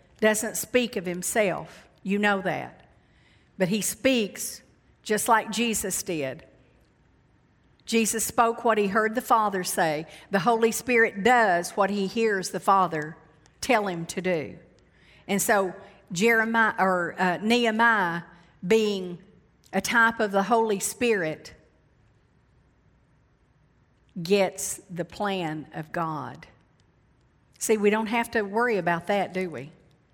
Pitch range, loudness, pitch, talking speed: 180-225 Hz, -25 LUFS, 200 Hz, 125 wpm